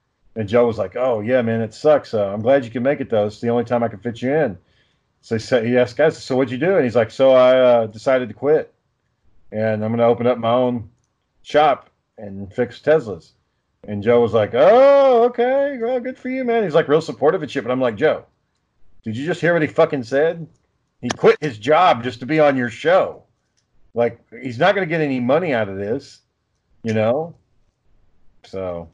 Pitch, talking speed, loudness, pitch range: 125 Hz, 225 wpm, -18 LUFS, 110-150 Hz